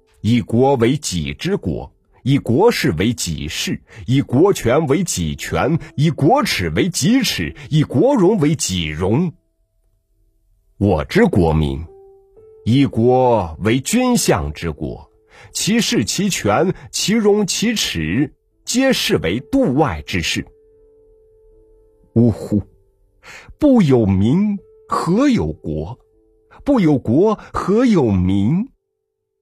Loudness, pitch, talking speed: -17 LUFS, 135 Hz, 145 characters per minute